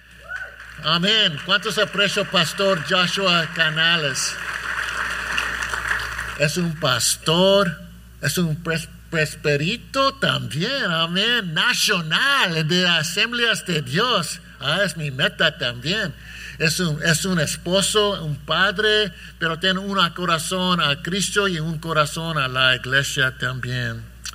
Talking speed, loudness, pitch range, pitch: 110 wpm, -20 LUFS, 150-195 Hz, 170 Hz